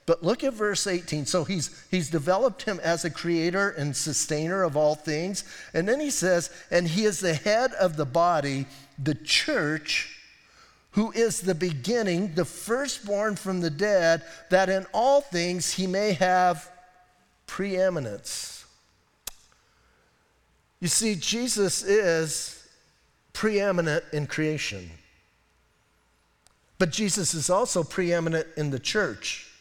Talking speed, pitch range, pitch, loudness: 130 wpm, 155-195 Hz, 175 Hz, -26 LUFS